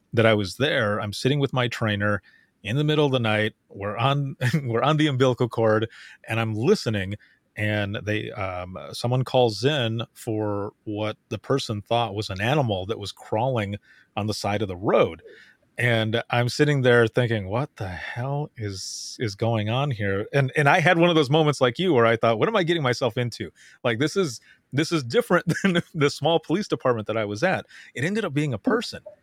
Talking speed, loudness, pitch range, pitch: 205 wpm, -24 LUFS, 110-145 Hz, 120 Hz